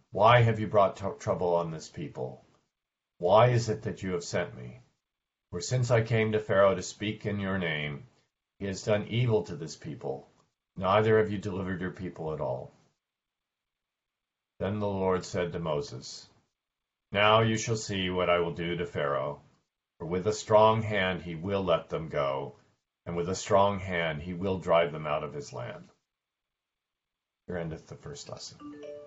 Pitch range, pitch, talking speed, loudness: 85-110 Hz, 100 Hz, 180 wpm, -29 LUFS